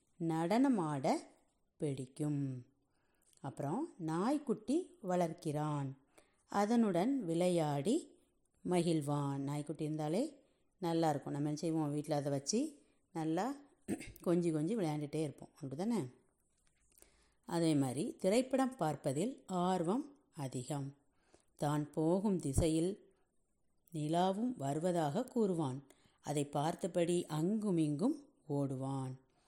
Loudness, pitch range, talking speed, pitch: -37 LUFS, 145-210 Hz, 80 wpm, 165 Hz